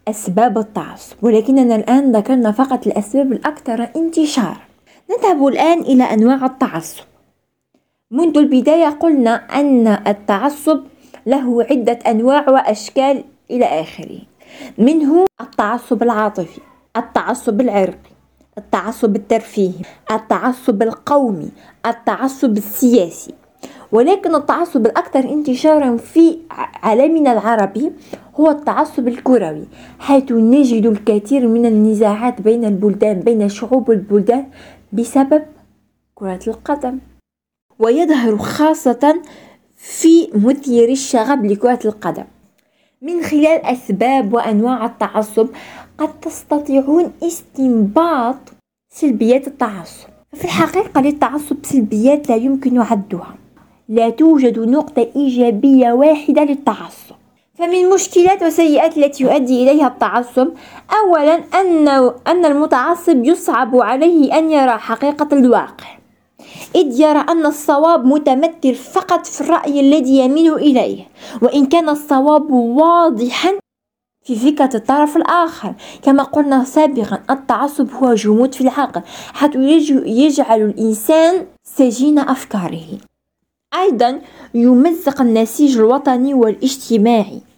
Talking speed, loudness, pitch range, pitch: 100 wpm, -14 LUFS, 230-300 Hz, 265 Hz